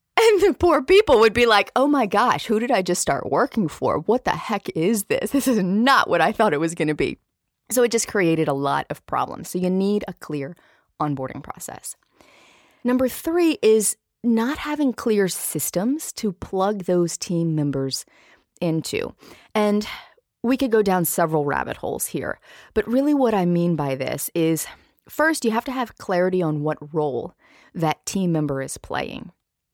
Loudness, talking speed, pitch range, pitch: -21 LUFS, 185 wpm, 165-250 Hz, 205 Hz